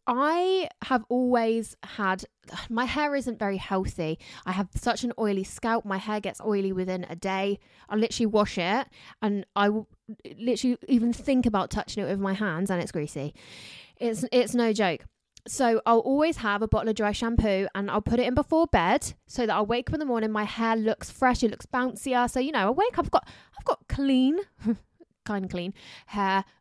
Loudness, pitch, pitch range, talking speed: -27 LUFS, 225 Hz, 200-250 Hz, 205 wpm